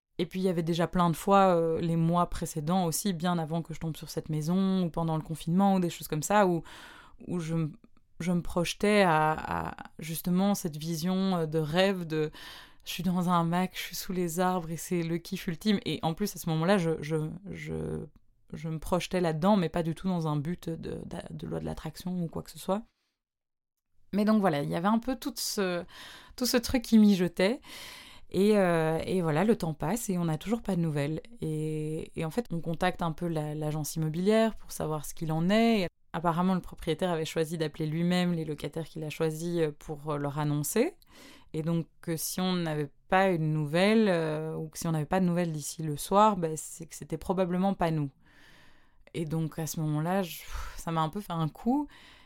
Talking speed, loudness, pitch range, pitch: 225 wpm, -30 LUFS, 160-190 Hz, 170 Hz